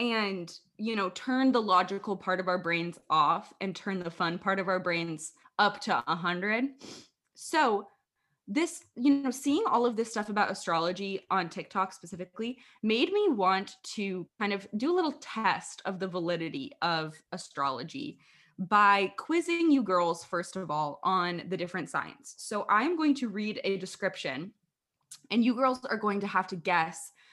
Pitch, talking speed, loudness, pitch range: 195 Hz, 175 wpm, -30 LUFS, 180-240 Hz